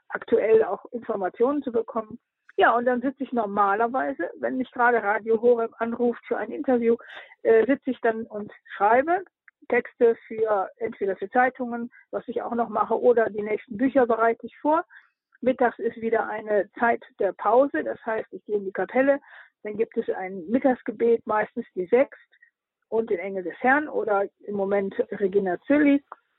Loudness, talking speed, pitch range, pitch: -24 LUFS, 170 wpm, 215-260 Hz, 235 Hz